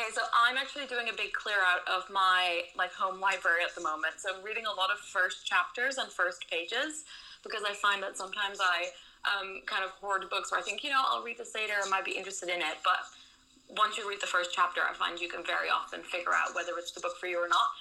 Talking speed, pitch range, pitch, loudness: 260 wpm, 180-215 Hz, 190 Hz, -31 LUFS